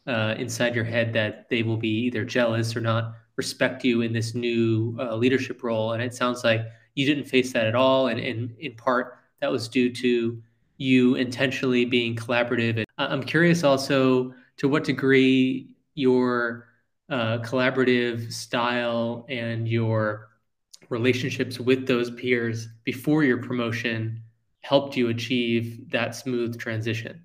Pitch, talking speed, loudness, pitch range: 120 Hz, 150 wpm, -24 LUFS, 115-130 Hz